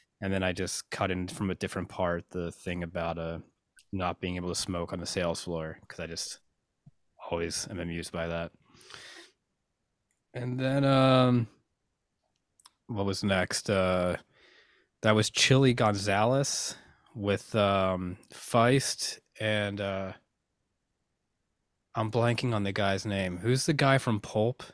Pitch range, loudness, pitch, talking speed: 90-115 Hz, -29 LUFS, 100 Hz, 140 wpm